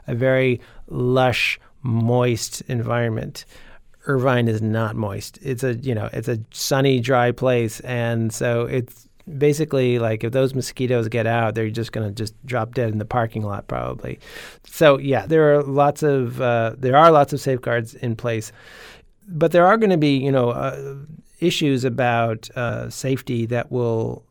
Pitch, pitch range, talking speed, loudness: 125 Hz, 115-135 Hz, 170 wpm, -20 LUFS